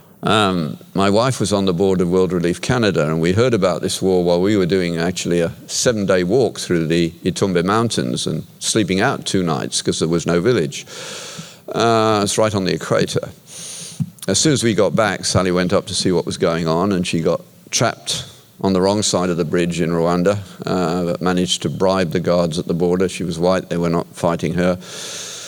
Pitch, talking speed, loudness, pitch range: 90 Hz, 215 wpm, -18 LUFS, 85-95 Hz